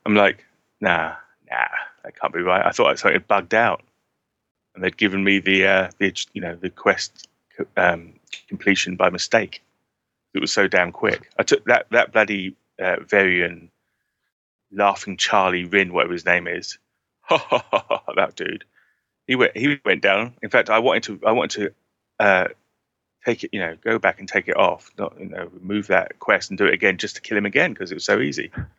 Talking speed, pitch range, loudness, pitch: 195 wpm, 90-105 Hz, -20 LUFS, 95 Hz